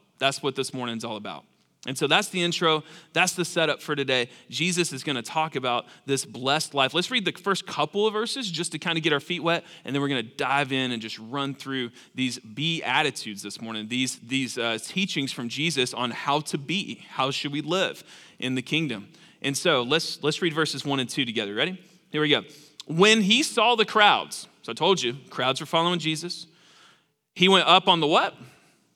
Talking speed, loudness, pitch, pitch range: 220 wpm, -25 LUFS, 150 Hz, 130-175 Hz